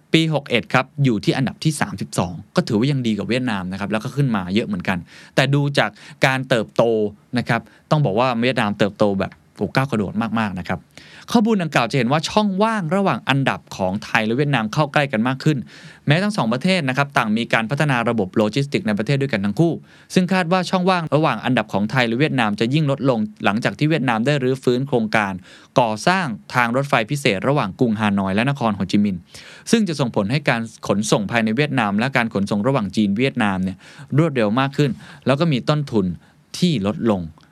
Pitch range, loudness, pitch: 110-150 Hz, -20 LUFS, 130 Hz